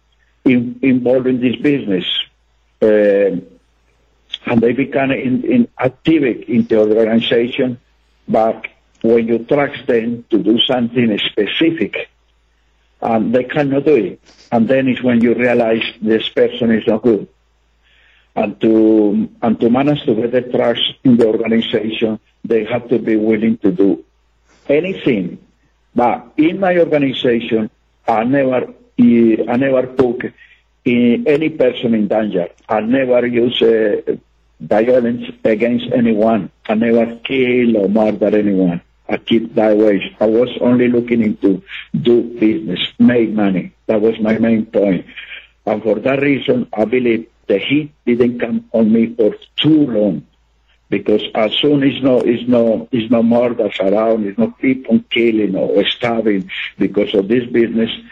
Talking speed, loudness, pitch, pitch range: 145 wpm, -15 LUFS, 115 Hz, 110-125 Hz